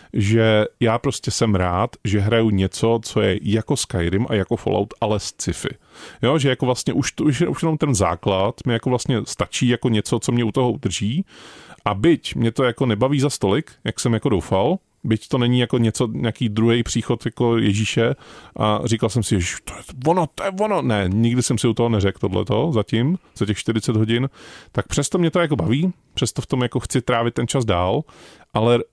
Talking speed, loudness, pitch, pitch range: 210 wpm, -20 LUFS, 120 Hz, 110-130 Hz